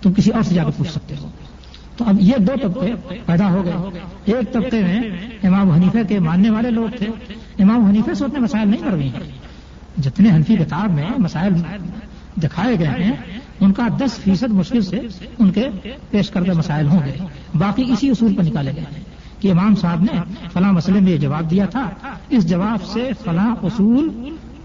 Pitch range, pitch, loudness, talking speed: 175-220 Hz, 195 Hz, -17 LUFS, 195 wpm